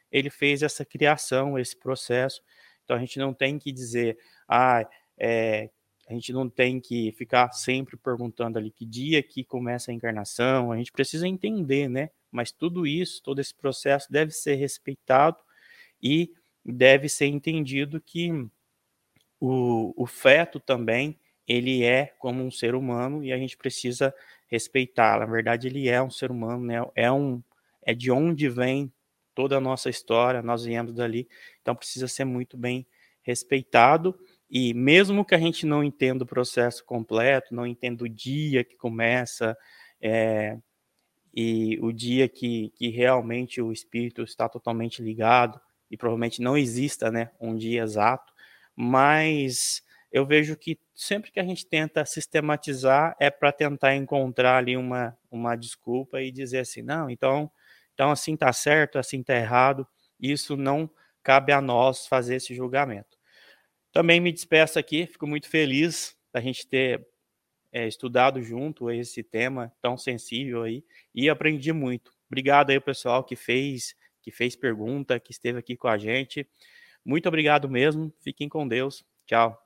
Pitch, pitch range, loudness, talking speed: 130 Hz, 120-145 Hz, -25 LUFS, 155 wpm